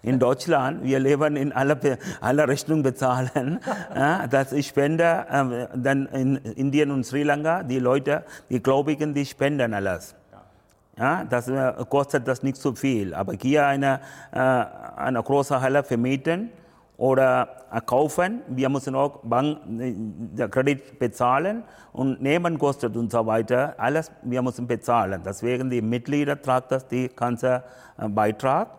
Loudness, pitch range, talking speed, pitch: -24 LUFS, 125-145 Hz, 150 wpm, 135 Hz